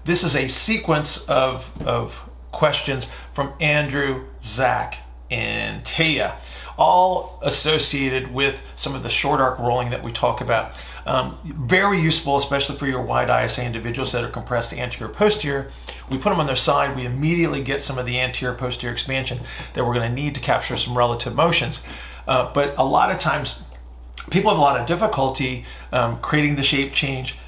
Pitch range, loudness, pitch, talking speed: 120-145 Hz, -21 LUFS, 130 Hz, 175 wpm